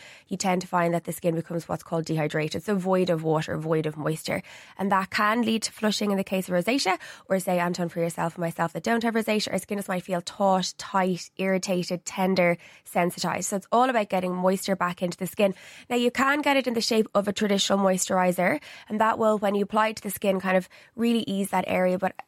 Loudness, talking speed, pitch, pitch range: -26 LUFS, 240 wpm, 190 Hz, 175-215 Hz